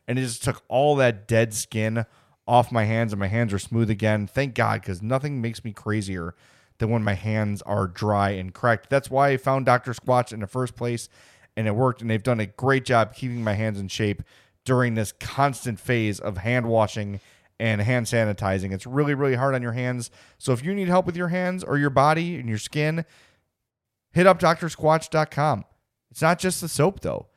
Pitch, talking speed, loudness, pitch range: 120 Hz, 210 wpm, -24 LUFS, 110-135 Hz